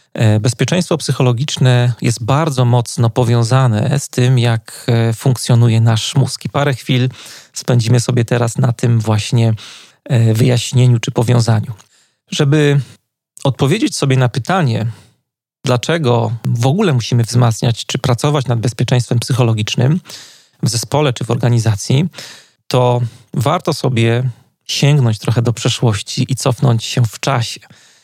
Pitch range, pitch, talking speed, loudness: 120-135 Hz, 125 Hz, 120 wpm, -15 LUFS